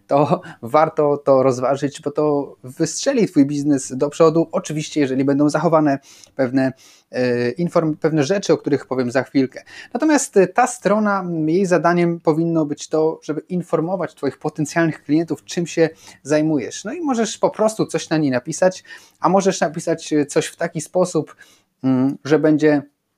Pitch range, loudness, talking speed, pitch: 145-170 Hz, -19 LUFS, 150 wpm, 155 Hz